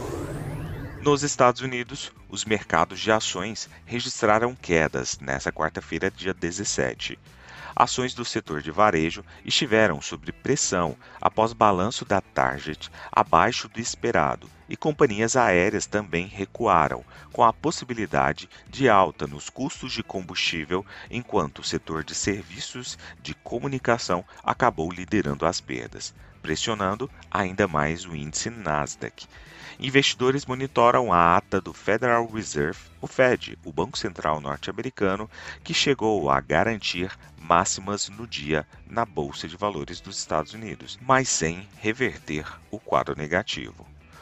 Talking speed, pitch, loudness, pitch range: 125 wpm, 95 Hz, -25 LUFS, 80-115 Hz